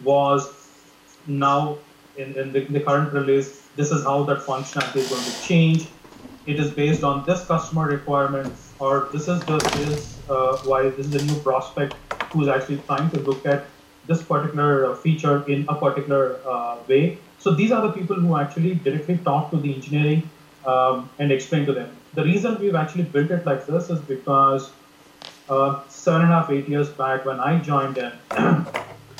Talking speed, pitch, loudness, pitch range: 185 wpm, 140 Hz, -22 LUFS, 135-155 Hz